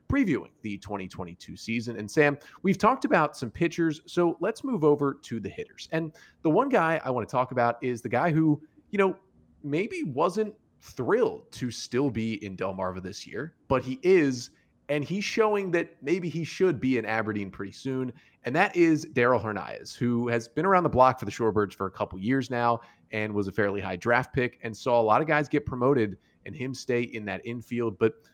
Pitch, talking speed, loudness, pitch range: 125 Hz, 210 wpm, -27 LUFS, 110-160 Hz